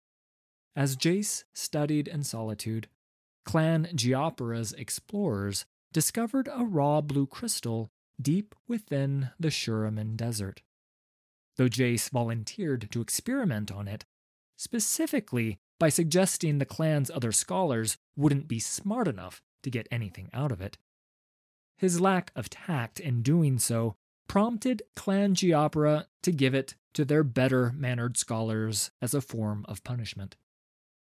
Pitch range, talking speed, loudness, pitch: 110-160 Hz, 125 wpm, -29 LUFS, 135 Hz